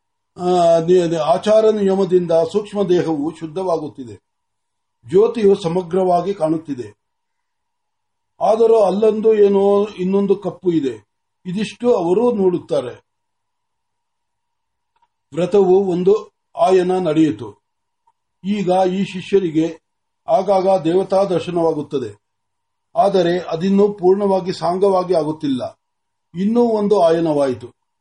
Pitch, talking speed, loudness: 195 Hz, 75 wpm, -17 LUFS